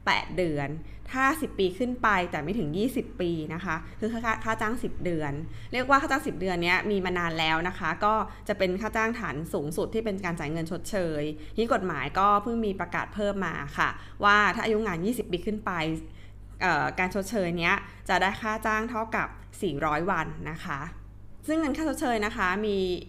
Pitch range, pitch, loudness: 165-220 Hz, 190 Hz, -28 LUFS